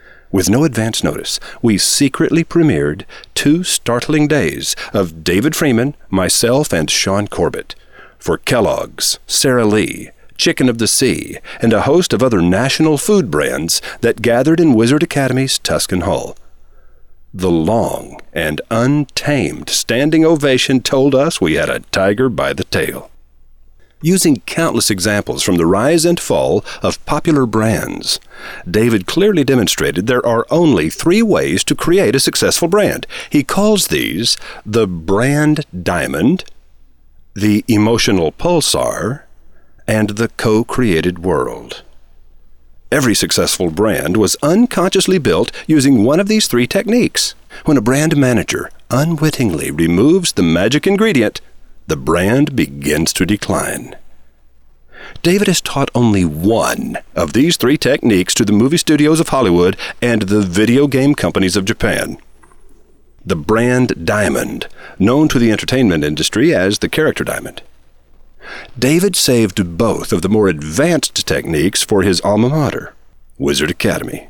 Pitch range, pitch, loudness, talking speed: 90-150 Hz, 115 Hz, -14 LUFS, 135 wpm